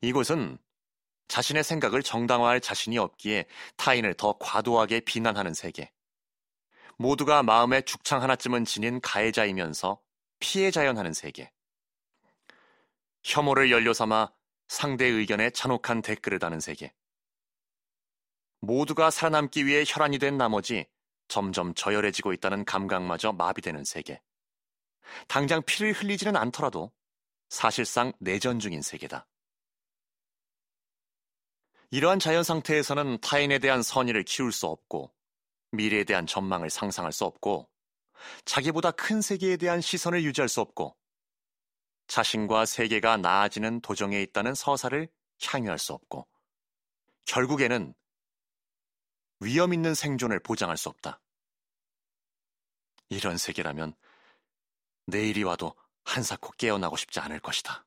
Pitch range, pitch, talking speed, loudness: 100-145 Hz, 120 Hz, 275 characters per minute, -27 LUFS